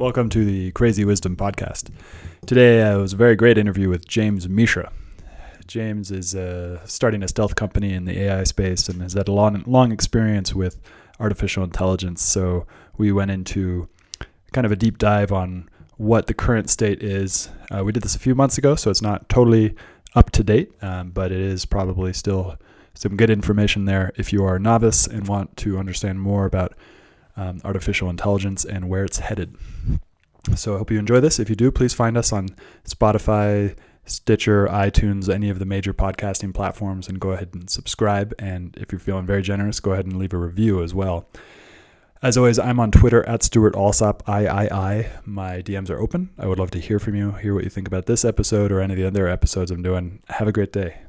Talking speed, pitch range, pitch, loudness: 205 wpm, 95-110 Hz, 100 Hz, -20 LUFS